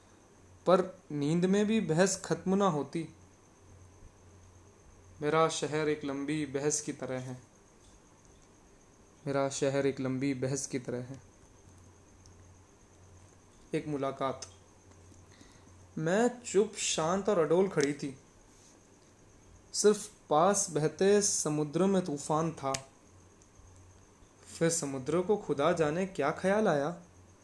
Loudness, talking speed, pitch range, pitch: -31 LUFS, 105 wpm, 100-160 Hz, 135 Hz